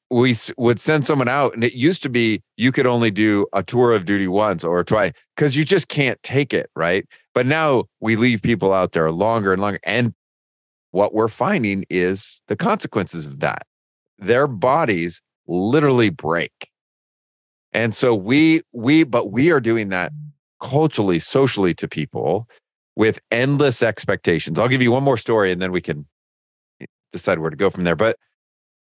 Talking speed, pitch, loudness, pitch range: 175 wpm, 115 Hz, -19 LUFS, 95-130 Hz